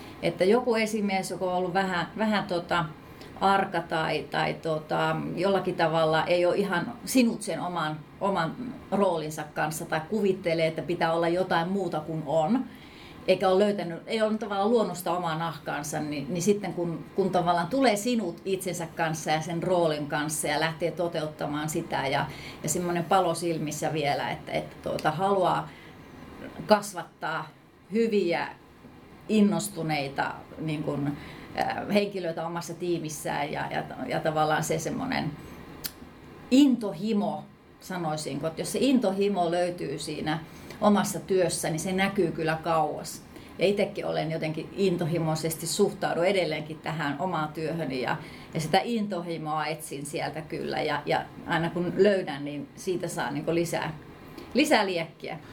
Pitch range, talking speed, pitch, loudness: 160-195 Hz, 140 wpm, 170 Hz, -28 LUFS